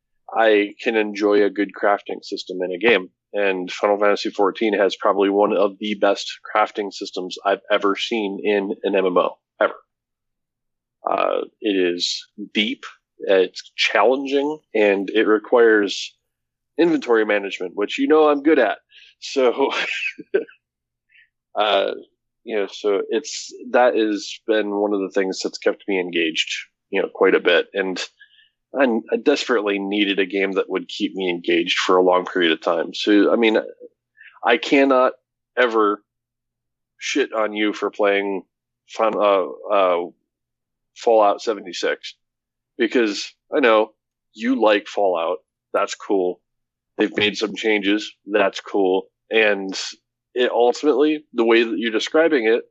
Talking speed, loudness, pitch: 140 wpm, -20 LUFS, 110 Hz